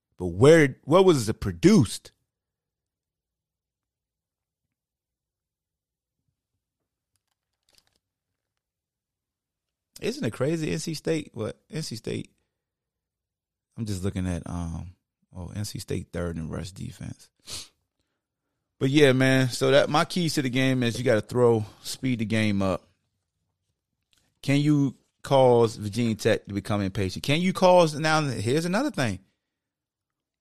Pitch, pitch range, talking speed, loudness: 120 Hz, 95-145 Hz, 120 wpm, -24 LUFS